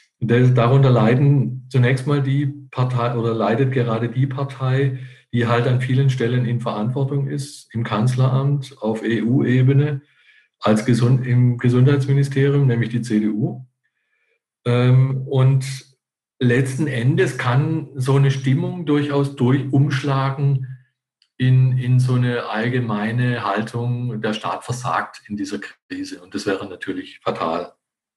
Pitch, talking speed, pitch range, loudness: 130 Hz, 120 wpm, 120-140 Hz, -19 LUFS